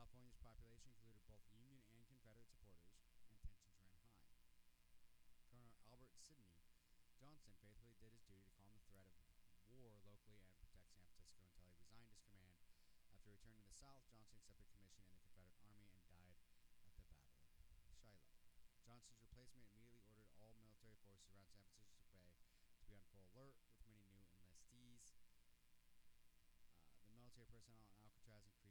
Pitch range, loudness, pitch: 90-115 Hz, -68 LUFS, 100 Hz